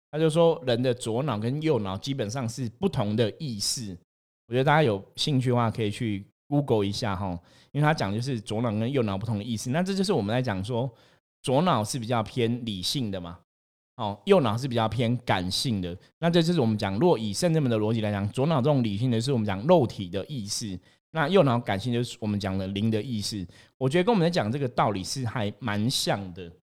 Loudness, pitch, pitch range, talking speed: -26 LUFS, 115 Hz, 105-135 Hz, 340 characters per minute